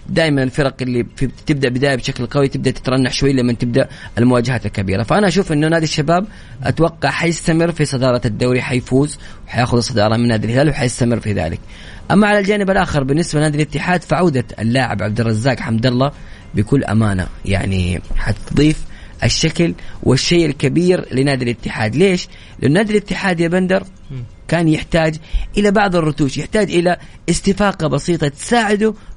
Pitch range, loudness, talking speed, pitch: 120-165 Hz, -16 LUFS, 150 wpm, 135 Hz